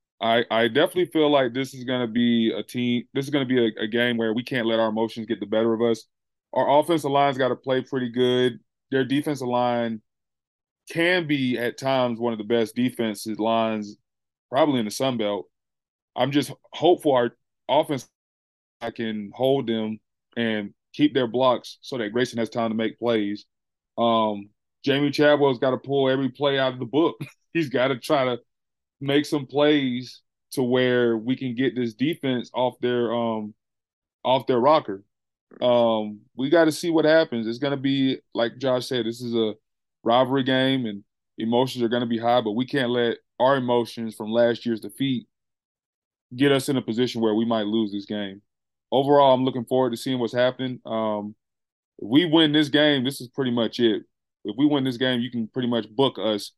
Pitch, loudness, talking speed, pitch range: 125 Hz, -23 LUFS, 195 wpm, 115-135 Hz